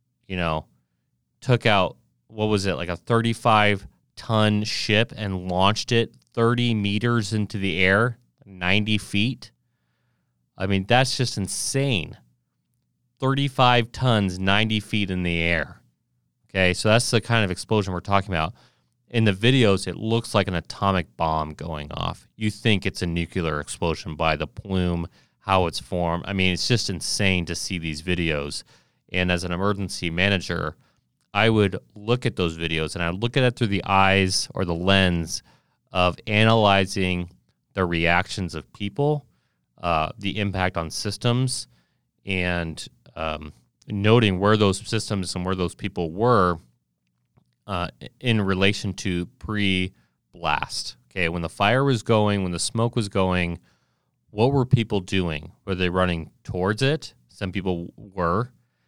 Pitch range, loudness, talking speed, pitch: 85-110 Hz, -23 LUFS, 150 wpm, 95 Hz